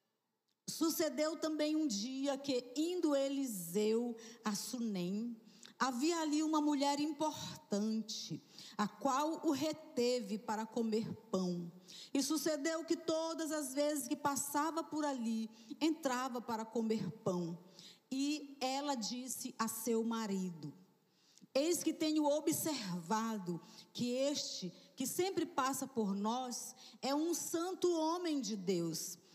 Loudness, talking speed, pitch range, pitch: -38 LUFS, 120 wpm, 215-300 Hz, 255 Hz